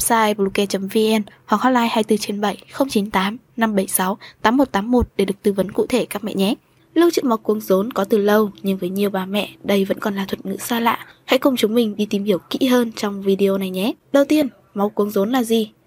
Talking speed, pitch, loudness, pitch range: 220 wpm, 210 Hz, -19 LUFS, 195-235 Hz